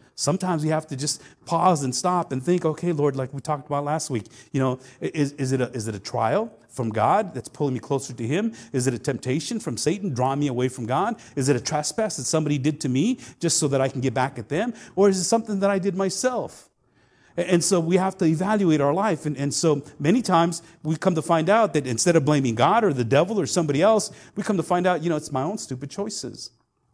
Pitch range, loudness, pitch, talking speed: 135-180 Hz, -23 LUFS, 150 Hz, 255 wpm